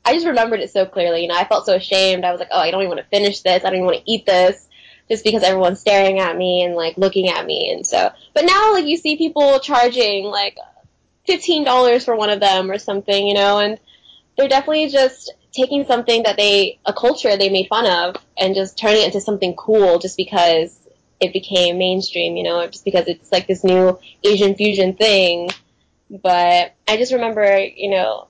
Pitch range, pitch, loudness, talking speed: 185-225 Hz, 200 Hz, -16 LUFS, 220 wpm